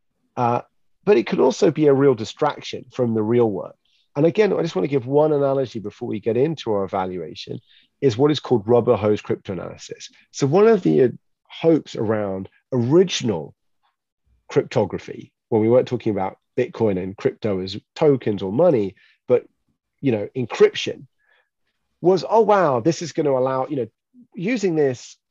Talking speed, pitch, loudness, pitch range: 170 wpm, 135 Hz, -20 LUFS, 110-165 Hz